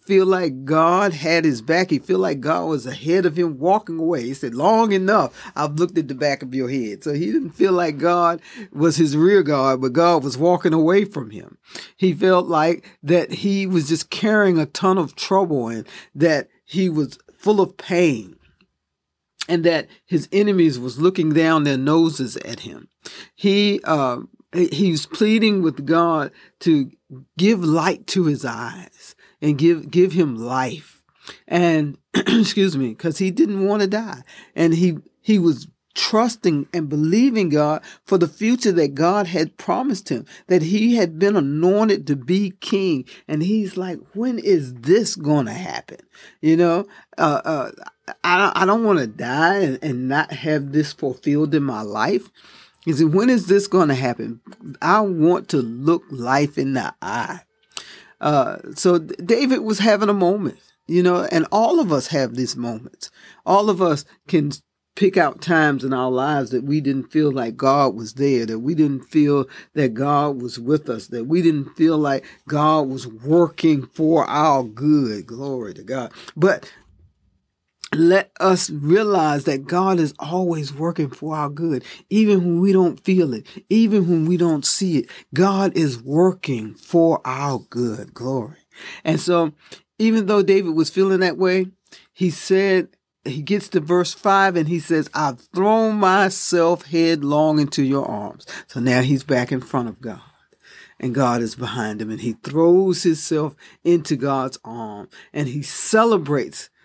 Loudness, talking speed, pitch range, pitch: -19 LUFS, 170 wpm, 140-185 Hz, 165 Hz